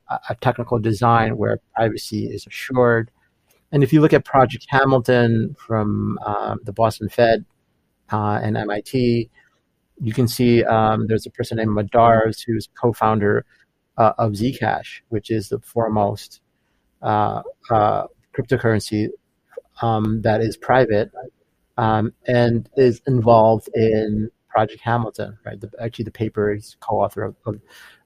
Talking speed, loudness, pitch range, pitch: 140 wpm, -19 LUFS, 110-120 Hz, 115 Hz